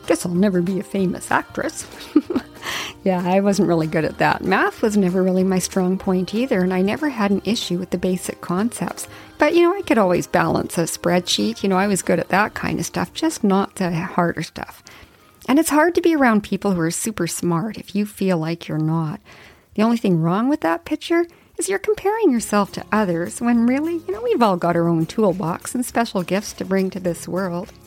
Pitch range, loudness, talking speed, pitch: 180-240 Hz, -20 LUFS, 225 wpm, 195 Hz